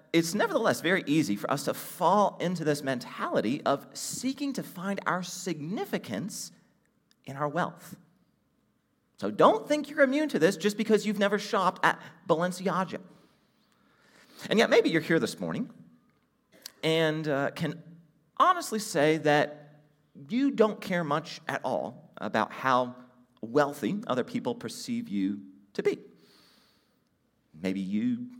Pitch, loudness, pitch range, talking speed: 170 Hz, -28 LUFS, 150-215 Hz, 135 wpm